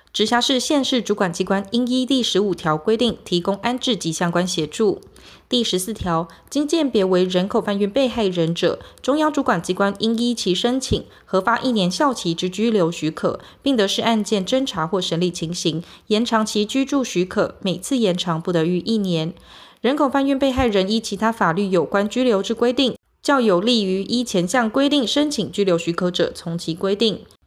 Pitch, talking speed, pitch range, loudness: 205 Hz, 285 characters per minute, 180-245 Hz, -20 LUFS